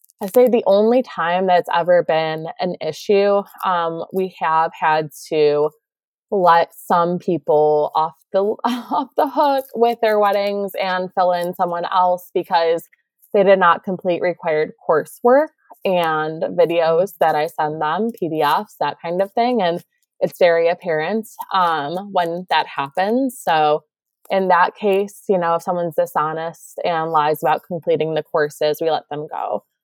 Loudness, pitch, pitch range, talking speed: -18 LUFS, 175 Hz, 160-200 Hz, 155 wpm